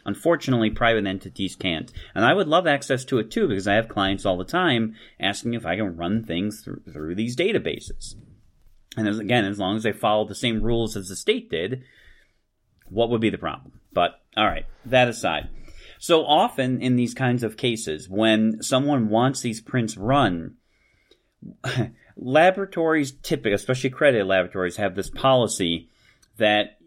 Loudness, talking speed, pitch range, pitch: -23 LUFS, 170 wpm, 100-130 Hz, 110 Hz